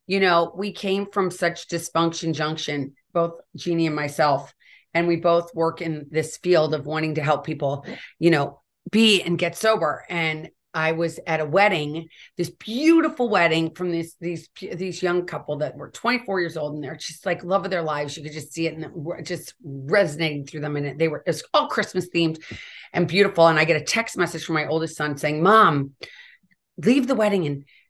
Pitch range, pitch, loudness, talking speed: 155-180 Hz, 165 Hz, -23 LUFS, 200 wpm